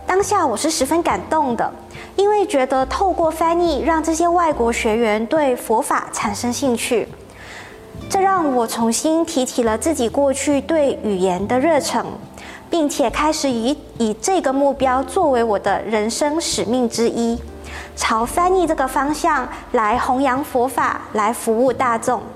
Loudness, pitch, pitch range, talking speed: -18 LUFS, 270 Hz, 235-320 Hz, 230 characters per minute